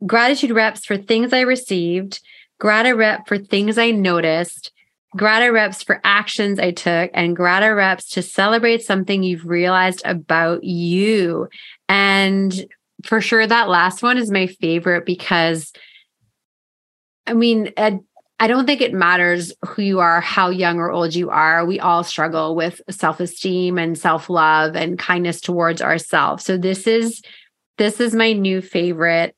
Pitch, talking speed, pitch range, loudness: 185 Hz, 150 wpm, 175-215 Hz, -17 LUFS